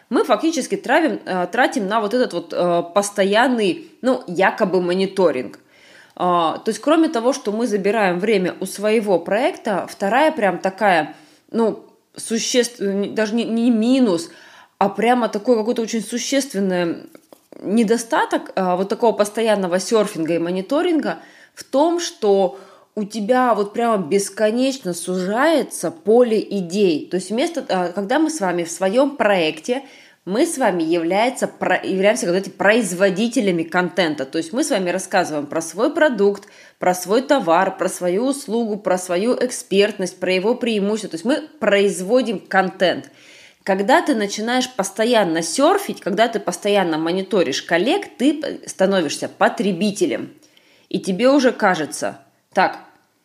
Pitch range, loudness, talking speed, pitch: 185-250 Hz, -19 LUFS, 135 wpm, 210 Hz